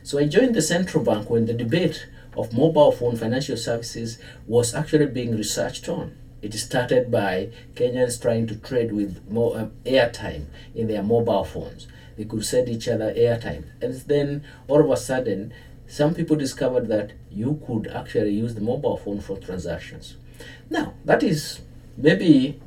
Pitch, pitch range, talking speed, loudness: 120 Hz, 115-145 Hz, 165 wpm, -23 LUFS